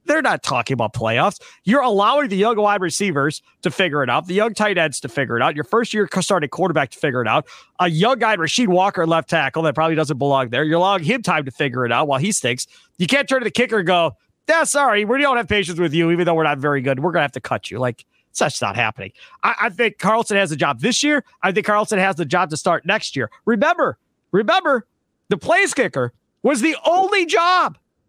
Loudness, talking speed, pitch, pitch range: -18 LUFS, 250 wpm, 180 Hz, 150-220 Hz